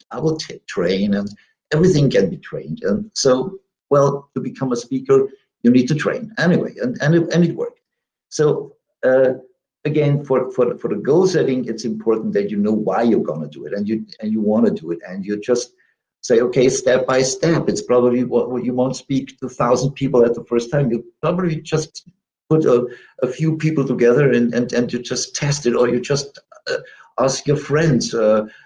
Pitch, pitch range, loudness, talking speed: 130 Hz, 120-155 Hz, -18 LUFS, 215 wpm